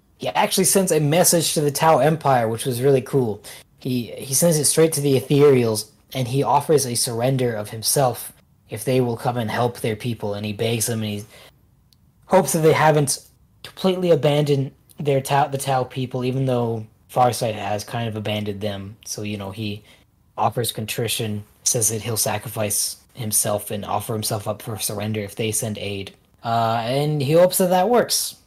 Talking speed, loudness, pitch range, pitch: 190 wpm, -20 LUFS, 105-140 Hz, 120 Hz